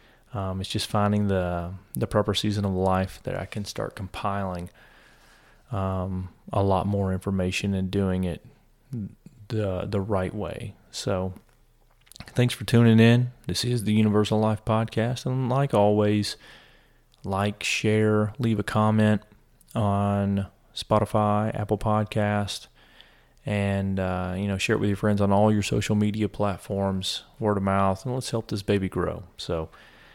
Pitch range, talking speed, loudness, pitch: 95-110 Hz, 150 wpm, -25 LUFS, 105 Hz